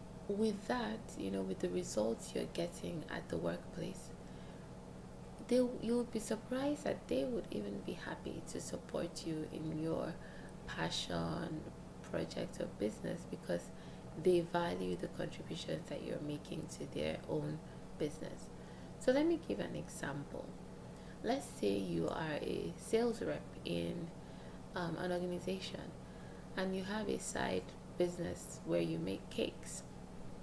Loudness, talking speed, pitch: -40 LUFS, 140 wpm, 175 Hz